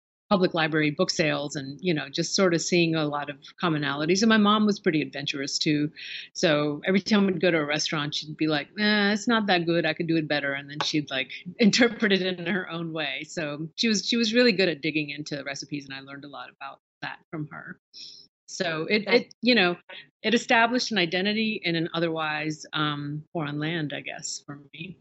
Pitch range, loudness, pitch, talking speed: 150-190 Hz, -25 LUFS, 165 Hz, 220 wpm